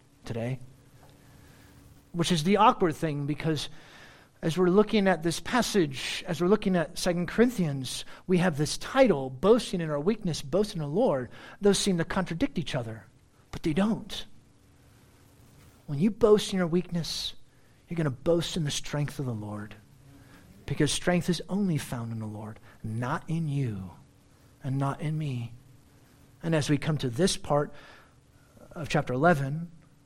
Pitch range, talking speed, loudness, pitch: 130-180 Hz, 160 wpm, -28 LUFS, 150 Hz